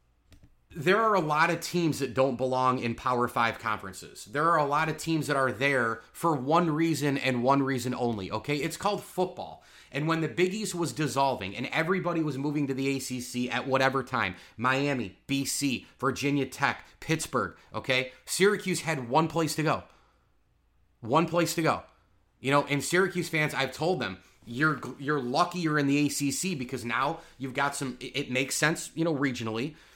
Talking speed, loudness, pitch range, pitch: 185 wpm, -28 LUFS, 130-160 Hz, 140 Hz